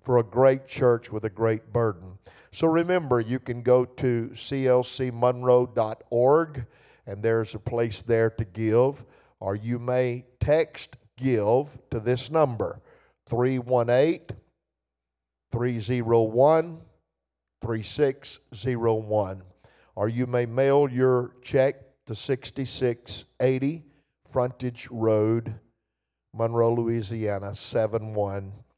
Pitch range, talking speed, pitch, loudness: 110-130 Hz, 95 wpm, 120 Hz, -25 LUFS